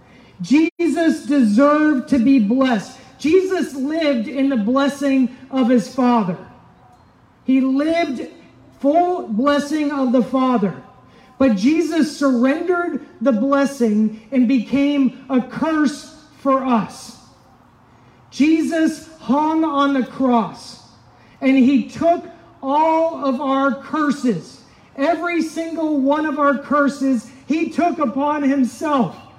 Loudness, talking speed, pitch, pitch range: -18 LUFS, 110 wpm, 275 Hz, 255-300 Hz